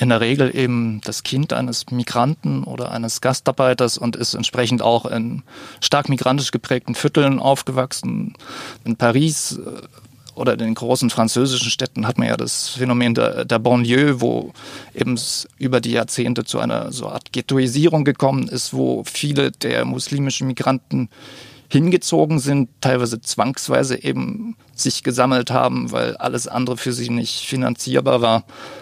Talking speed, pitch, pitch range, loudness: 145 wpm, 125 Hz, 120-135 Hz, -19 LUFS